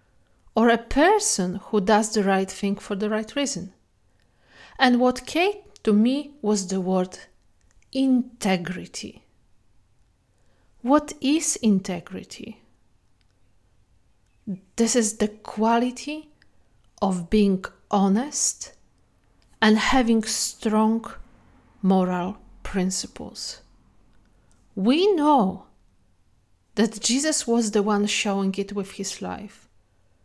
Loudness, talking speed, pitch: -23 LUFS, 95 wpm, 205 Hz